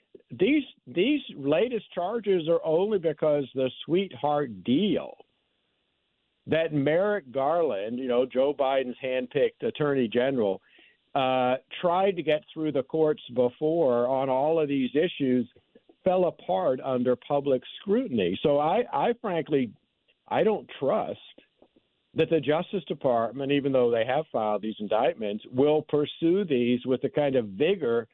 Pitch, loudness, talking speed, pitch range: 145 Hz, -26 LUFS, 140 wpm, 130-170 Hz